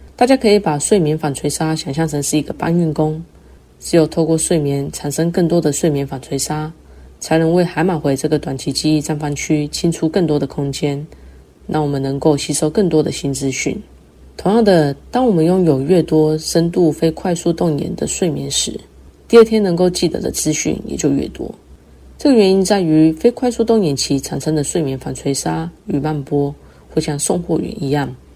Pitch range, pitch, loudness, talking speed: 140-170 Hz, 155 Hz, -16 LUFS, 285 characters per minute